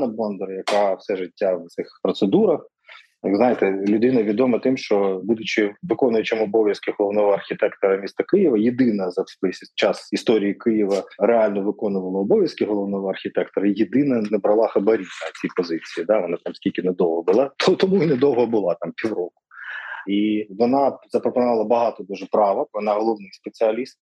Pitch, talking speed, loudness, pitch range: 105 Hz, 145 wpm, -21 LUFS, 100-120 Hz